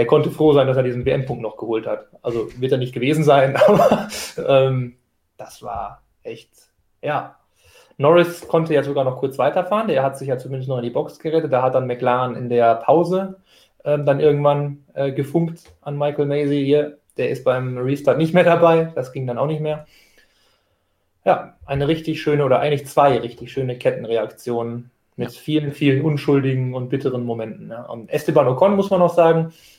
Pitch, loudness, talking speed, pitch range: 140 Hz, -19 LUFS, 190 wpm, 130-155 Hz